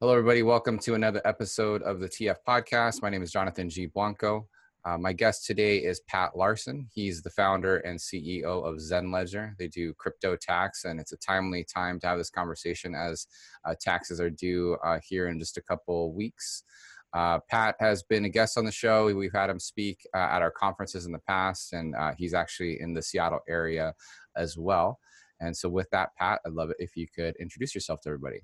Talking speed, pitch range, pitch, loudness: 215 wpm, 85-105 Hz, 90 Hz, -29 LUFS